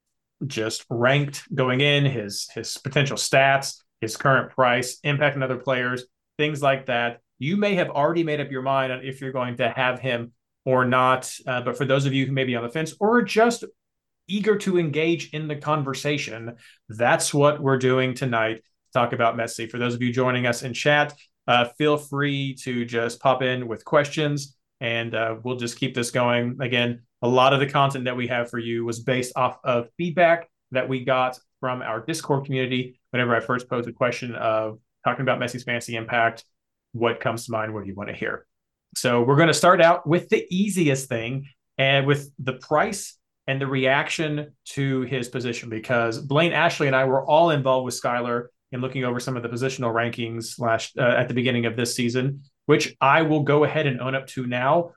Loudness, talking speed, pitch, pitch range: -23 LUFS, 205 wpm, 130 Hz, 120-145 Hz